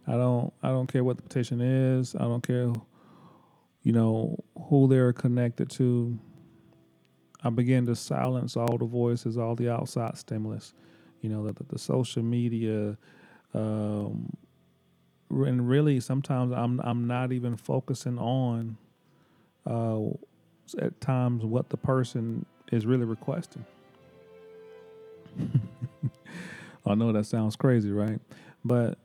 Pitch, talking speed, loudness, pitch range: 120 Hz, 130 wpm, -29 LUFS, 115-130 Hz